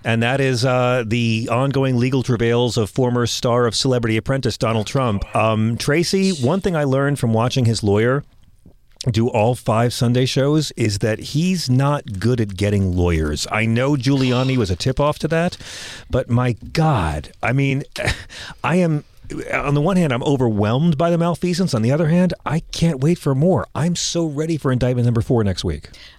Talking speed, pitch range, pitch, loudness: 190 wpm, 115-145 Hz, 125 Hz, -19 LUFS